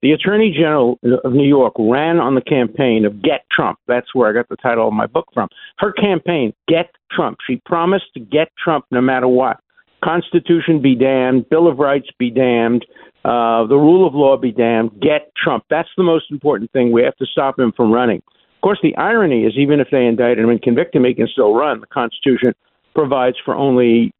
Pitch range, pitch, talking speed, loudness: 120-165 Hz, 135 Hz, 215 wpm, -15 LUFS